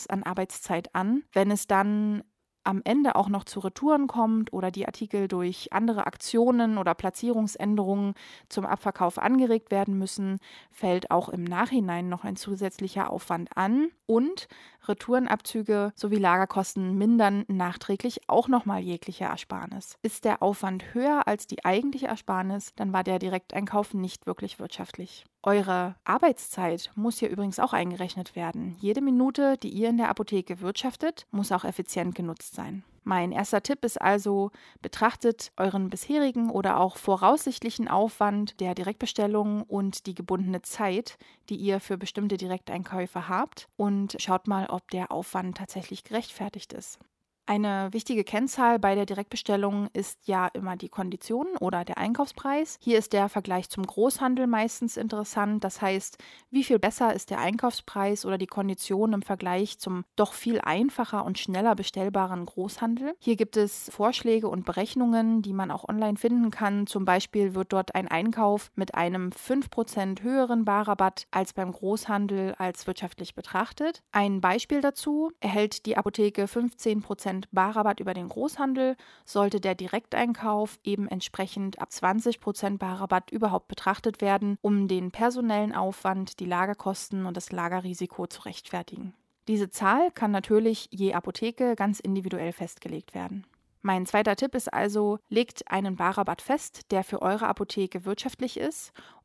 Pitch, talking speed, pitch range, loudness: 200 Hz, 150 wpm, 190-225 Hz, -28 LUFS